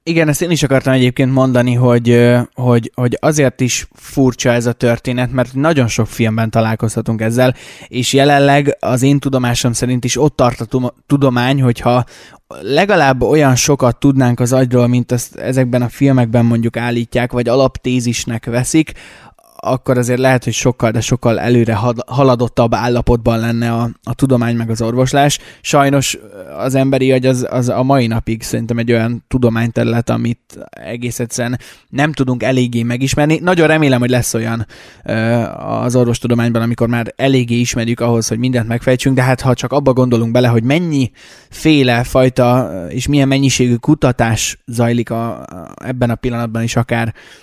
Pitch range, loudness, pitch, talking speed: 120-130 Hz, -14 LUFS, 125 Hz, 155 wpm